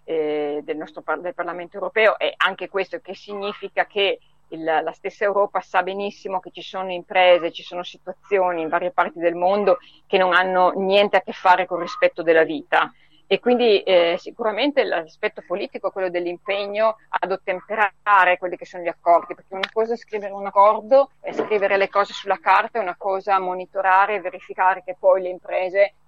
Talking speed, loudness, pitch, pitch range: 190 wpm, -21 LUFS, 190 Hz, 175-200 Hz